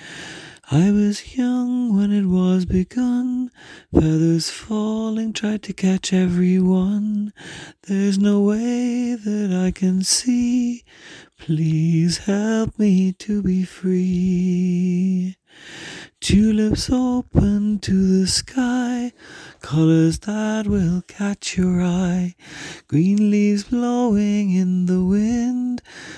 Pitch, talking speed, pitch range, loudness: 200 Hz, 100 wpm, 180-220 Hz, -19 LUFS